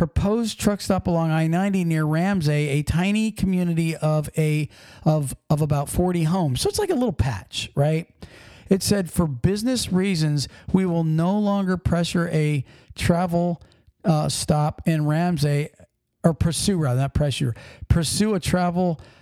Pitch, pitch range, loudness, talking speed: 165 Hz, 150-185 Hz, -22 LUFS, 150 wpm